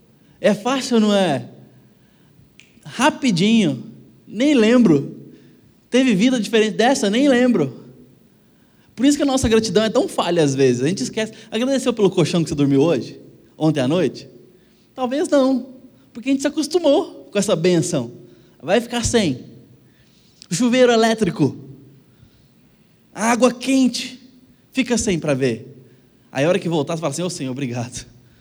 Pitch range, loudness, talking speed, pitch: 150-250 Hz, -18 LUFS, 150 wpm, 215 Hz